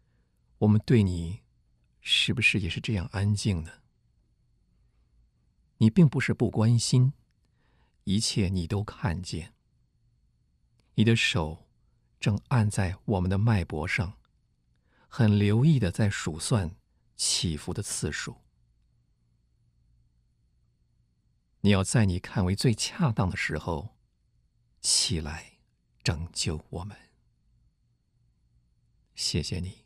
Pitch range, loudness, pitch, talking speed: 75-115 Hz, -27 LUFS, 100 Hz, 145 characters per minute